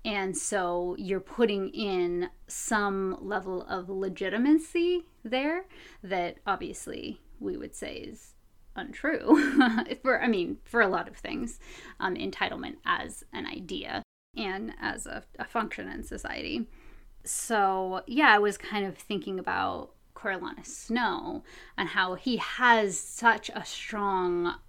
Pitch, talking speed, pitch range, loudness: 205 Hz, 130 wpm, 185-250 Hz, -29 LUFS